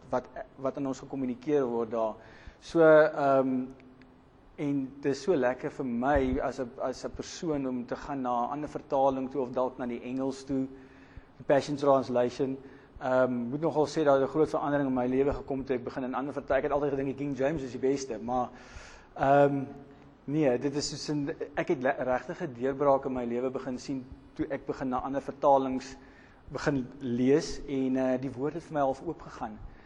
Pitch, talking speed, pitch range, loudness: 135 Hz, 190 wpm, 130-145 Hz, -30 LUFS